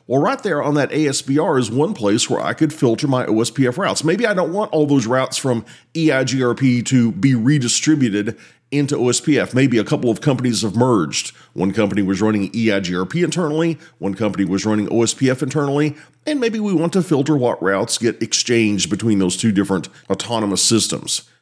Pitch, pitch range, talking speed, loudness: 125 Hz, 110-150 Hz, 180 wpm, -18 LUFS